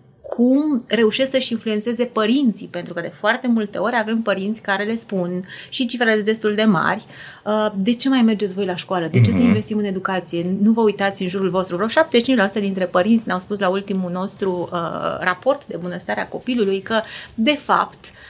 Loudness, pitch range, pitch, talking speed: -19 LUFS, 190-230 Hz, 210 Hz, 195 wpm